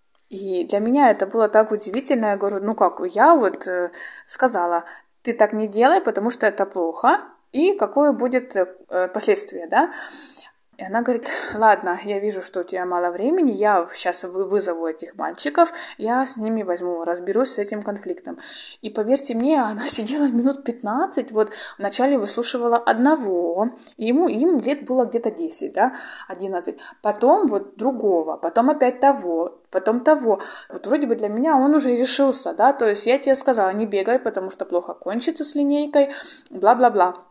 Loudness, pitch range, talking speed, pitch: -20 LUFS, 195-270 Hz, 165 wpm, 225 Hz